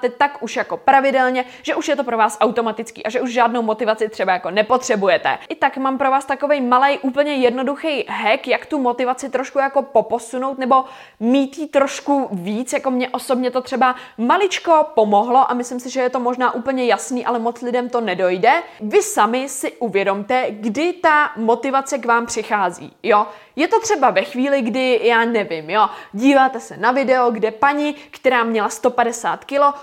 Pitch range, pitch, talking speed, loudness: 230-275 Hz, 255 Hz, 185 wpm, -18 LUFS